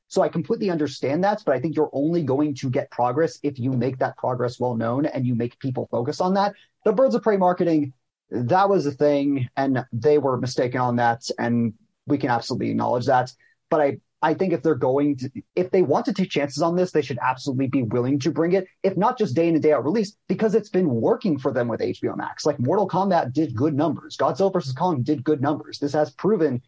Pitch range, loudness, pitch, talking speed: 130-180 Hz, -23 LUFS, 150 Hz, 240 wpm